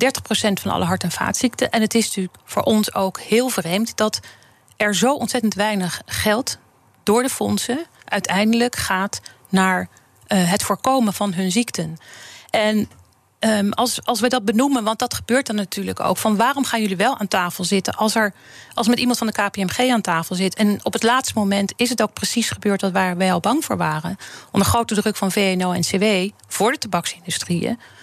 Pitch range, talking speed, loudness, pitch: 190-235 Hz, 195 wpm, -20 LUFS, 210 Hz